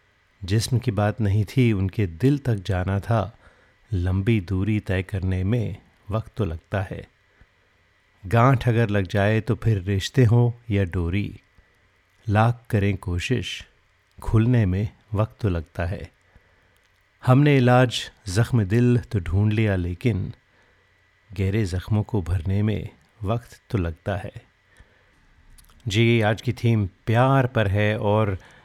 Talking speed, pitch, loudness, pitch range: 130 wpm, 105 Hz, -23 LUFS, 95-115 Hz